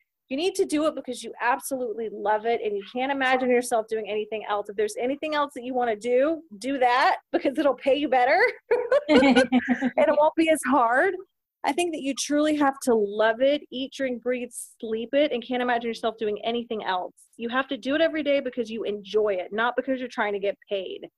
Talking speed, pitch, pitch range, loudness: 225 wpm, 250 Hz, 225-285 Hz, -25 LUFS